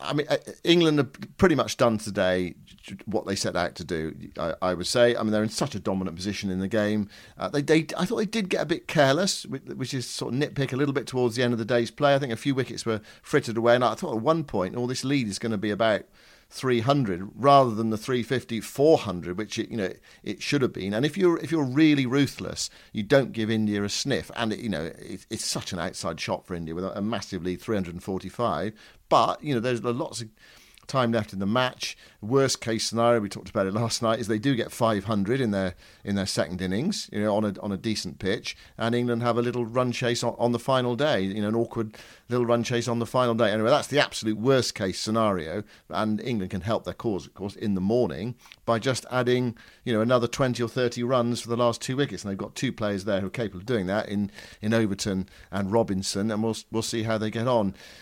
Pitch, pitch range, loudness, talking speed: 115 Hz, 100-125 Hz, -26 LUFS, 250 wpm